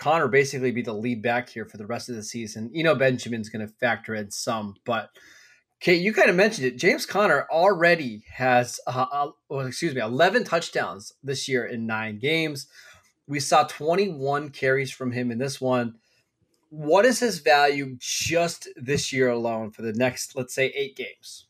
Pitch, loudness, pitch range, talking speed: 130 Hz, -24 LUFS, 120-150 Hz, 195 wpm